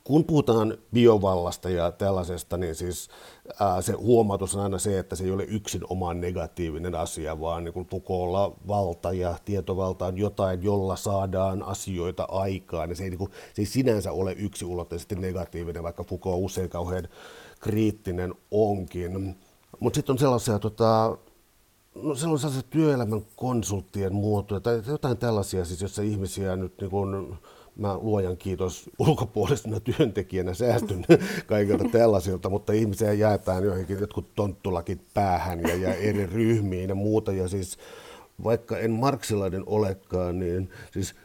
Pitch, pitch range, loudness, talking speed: 100 Hz, 90-110 Hz, -27 LUFS, 140 wpm